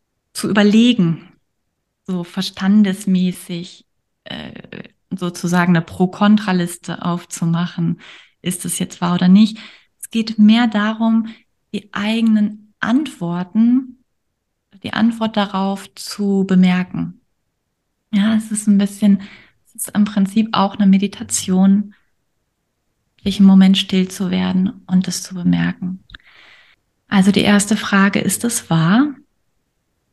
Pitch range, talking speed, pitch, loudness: 185-215 Hz, 110 wpm, 195 Hz, -16 LUFS